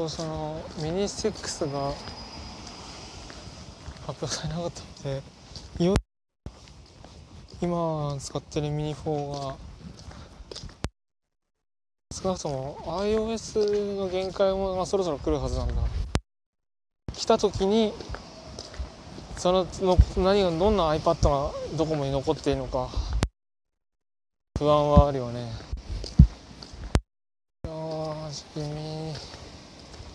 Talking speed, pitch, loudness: 175 characters per minute, 150 Hz, -27 LUFS